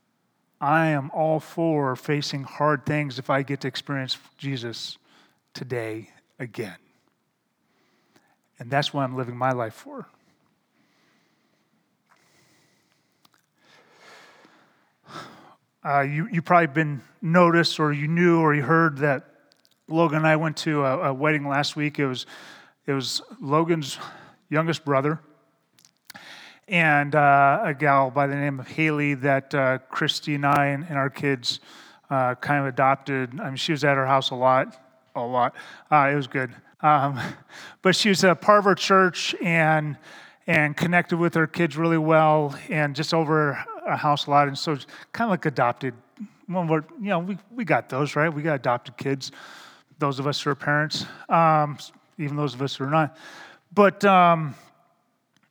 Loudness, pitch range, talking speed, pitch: -23 LUFS, 135-160 Hz, 160 wpm, 145 Hz